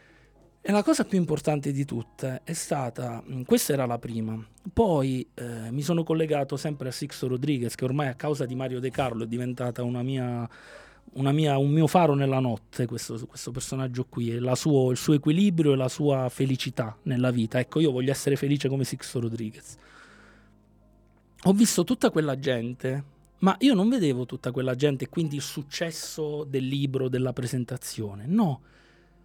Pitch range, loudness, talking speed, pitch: 125-150 Hz, -27 LUFS, 170 wpm, 135 Hz